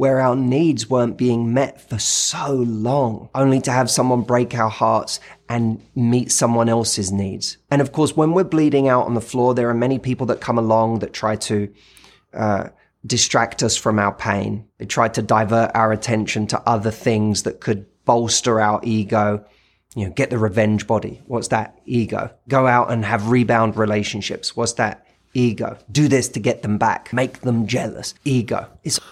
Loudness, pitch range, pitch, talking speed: -19 LUFS, 110-125 Hz, 115 Hz, 185 wpm